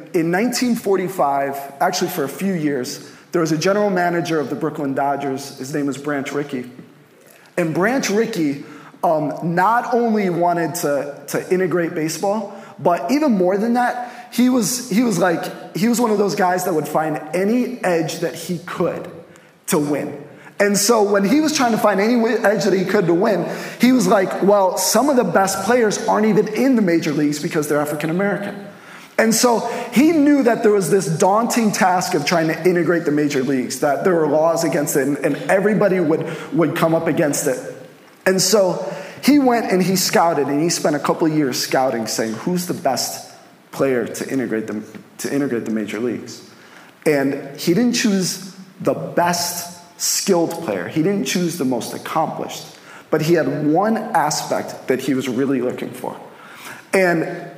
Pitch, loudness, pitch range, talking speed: 175 Hz, -18 LUFS, 155-205 Hz, 185 wpm